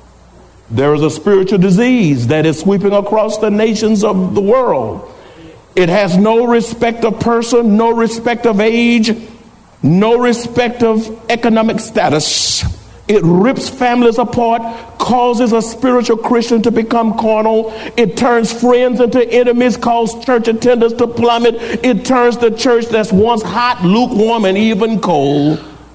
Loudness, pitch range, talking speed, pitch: -12 LUFS, 205-235 Hz, 140 wpm, 225 Hz